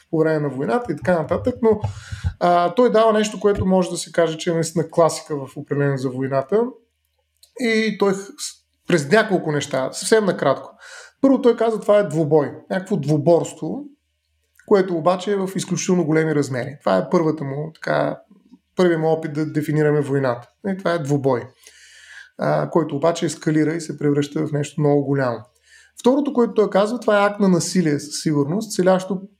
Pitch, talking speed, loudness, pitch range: 165 Hz, 175 wpm, -20 LUFS, 145-200 Hz